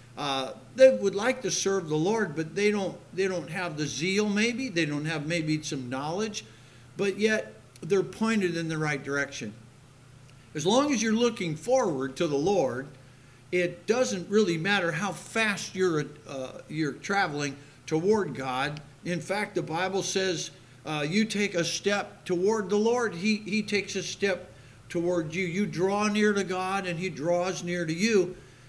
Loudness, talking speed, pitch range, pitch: -28 LUFS, 175 wpm, 150-200 Hz, 180 Hz